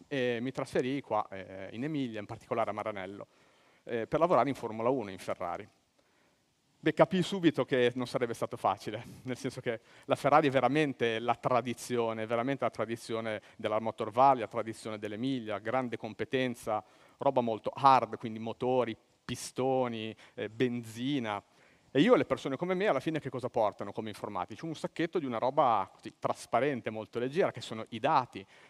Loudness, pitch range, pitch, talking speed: -32 LUFS, 110-135 Hz, 125 Hz, 175 wpm